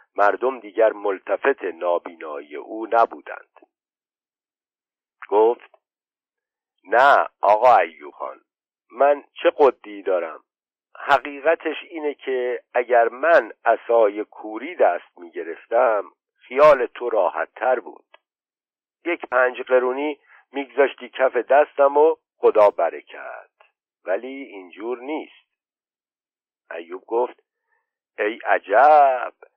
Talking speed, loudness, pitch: 90 wpm, -20 LUFS, 165 Hz